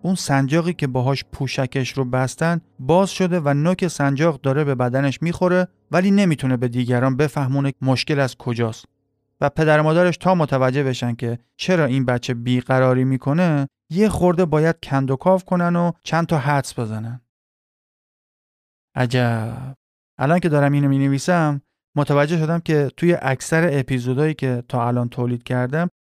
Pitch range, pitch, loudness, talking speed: 130-165 Hz, 140 Hz, -20 LUFS, 150 wpm